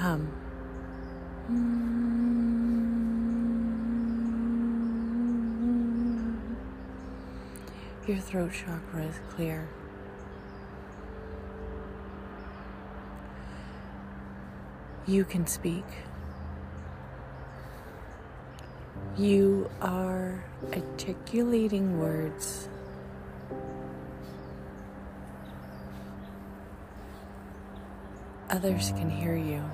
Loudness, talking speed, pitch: -32 LUFS, 35 wpm, 100 Hz